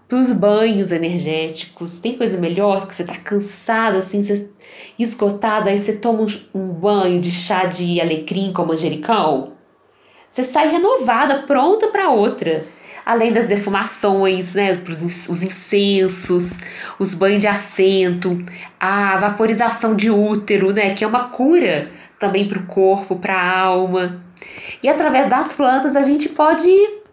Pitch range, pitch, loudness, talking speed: 185-230 Hz, 200 Hz, -17 LUFS, 140 wpm